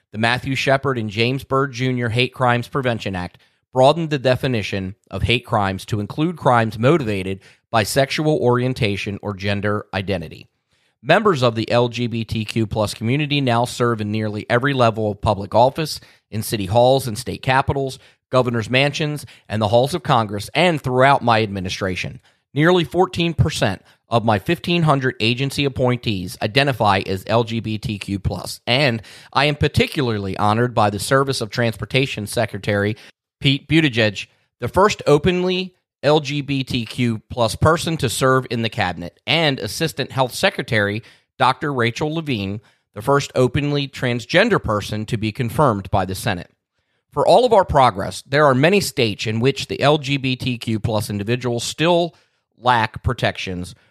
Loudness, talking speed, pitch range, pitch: -19 LUFS, 145 wpm, 110-140 Hz, 120 Hz